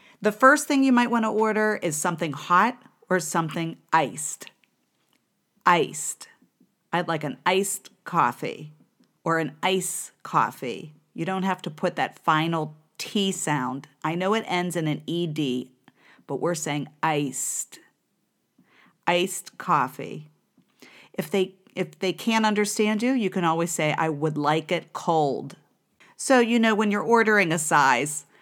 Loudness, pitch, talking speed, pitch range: -24 LUFS, 175 Hz, 150 wpm, 155-205 Hz